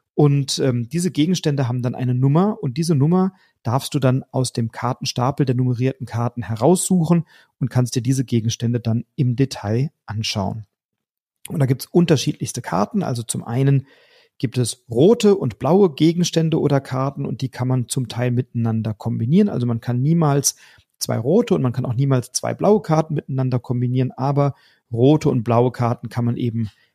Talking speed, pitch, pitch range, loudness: 175 wpm, 130 Hz, 120-150 Hz, -20 LUFS